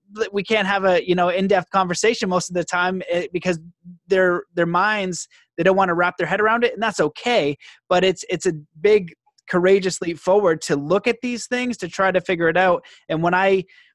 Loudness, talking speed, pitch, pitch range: -20 LUFS, 215 wpm, 185 Hz, 175-200 Hz